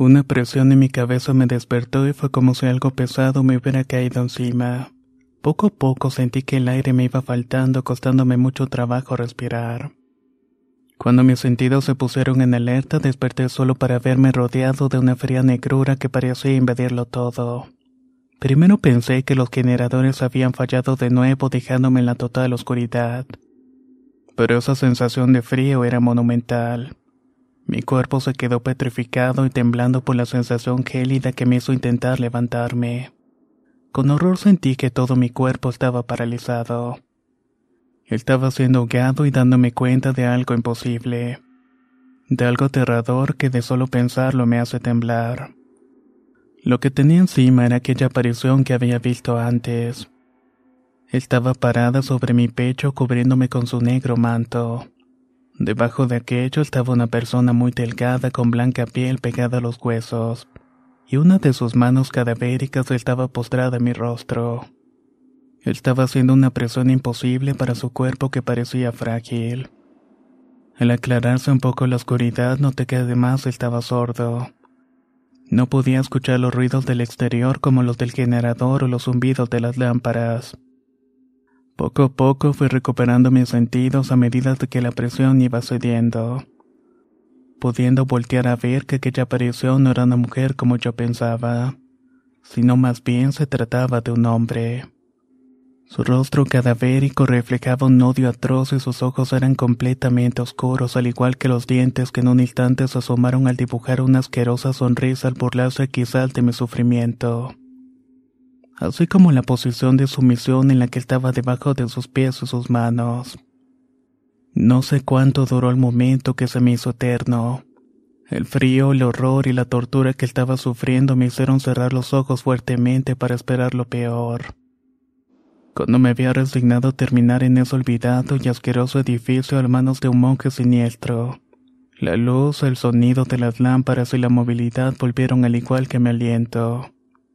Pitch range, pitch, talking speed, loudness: 125-135 Hz, 125 Hz, 155 wpm, -18 LUFS